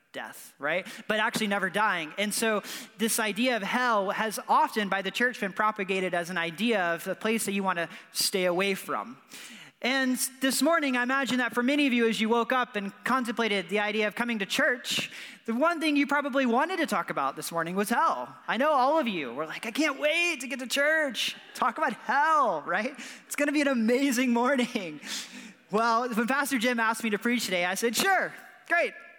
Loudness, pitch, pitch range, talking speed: -27 LUFS, 235 Hz, 205-270 Hz, 215 wpm